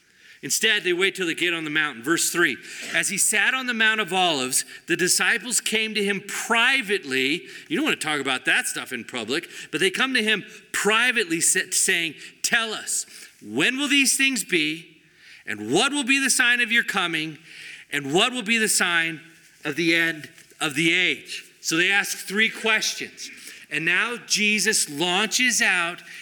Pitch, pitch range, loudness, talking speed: 200 Hz, 165-230 Hz, -21 LUFS, 185 wpm